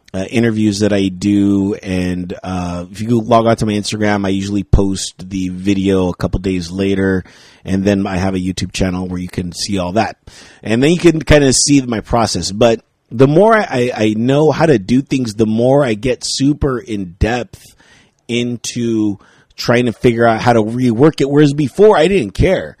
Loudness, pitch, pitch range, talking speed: -14 LUFS, 110 Hz, 95-125 Hz, 200 wpm